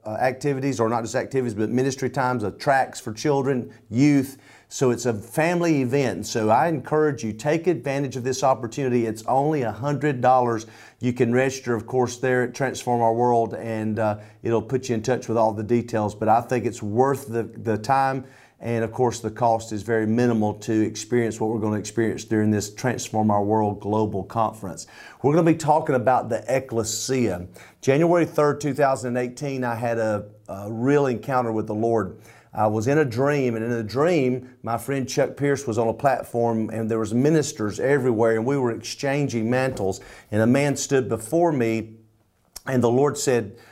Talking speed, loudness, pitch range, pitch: 190 wpm, -23 LUFS, 110-135 Hz, 120 Hz